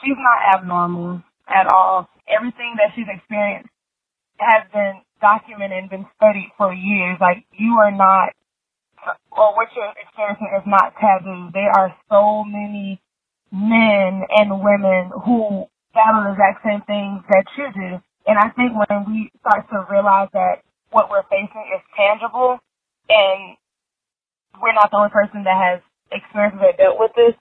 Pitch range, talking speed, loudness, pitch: 195-220 Hz, 160 wpm, -17 LUFS, 205 Hz